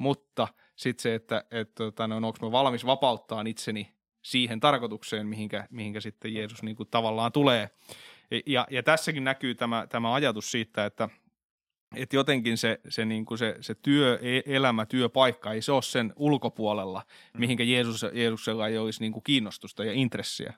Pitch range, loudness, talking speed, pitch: 110-130 Hz, -28 LUFS, 160 wpm, 115 Hz